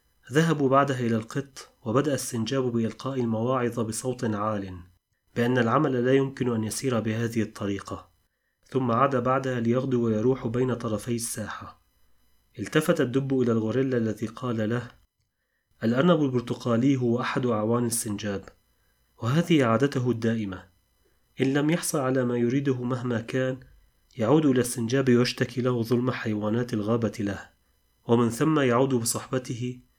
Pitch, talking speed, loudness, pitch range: 120 Hz, 125 wpm, -26 LUFS, 115-130 Hz